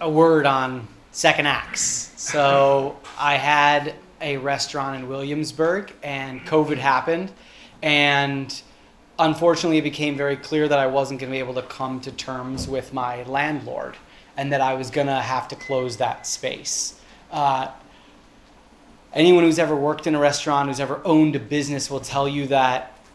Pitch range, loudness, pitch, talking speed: 135-150 Hz, -21 LUFS, 140 Hz, 165 wpm